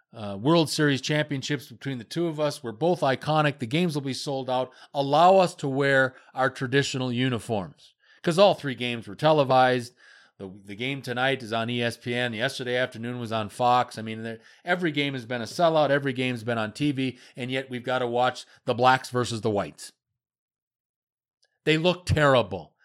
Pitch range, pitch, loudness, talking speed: 120-145 Hz, 130 Hz, -25 LUFS, 185 wpm